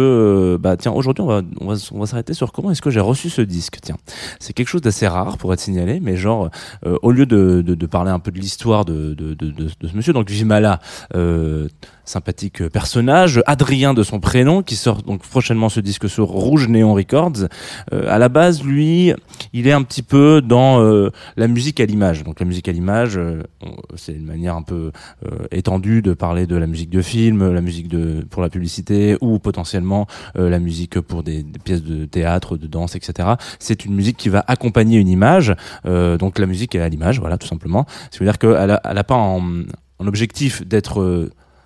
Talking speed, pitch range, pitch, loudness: 215 wpm, 90-115 Hz, 100 Hz, -17 LUFS